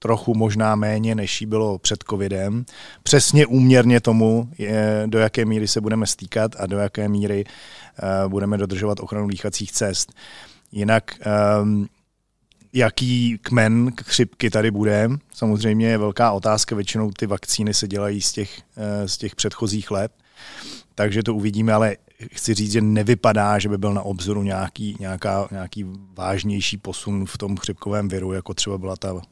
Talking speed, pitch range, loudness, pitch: 150 wpm, 100-110 Hz, -21 LUFS, 105 Hz